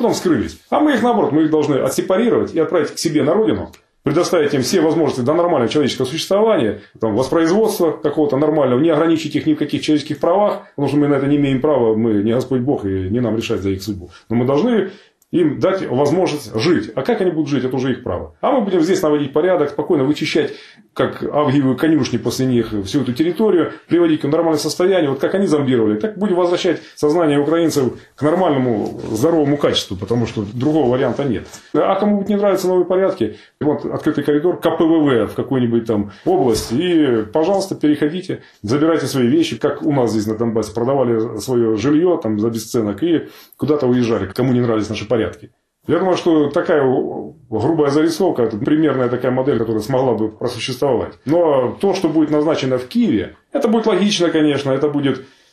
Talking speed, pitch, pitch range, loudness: 190 wpm, 145 Hz, 120-165 Hz, -17 LUFS